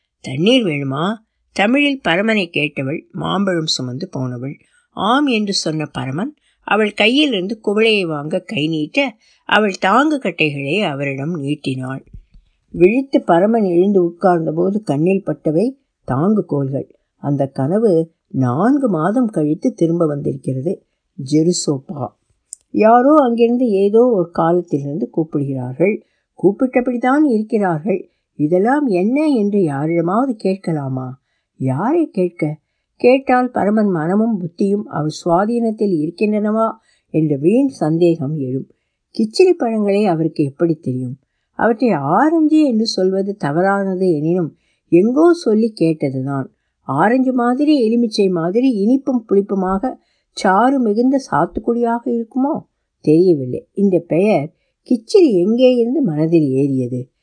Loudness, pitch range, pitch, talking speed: -16 LUFS, 155-235 Hz, 190 Hz, 100 wpm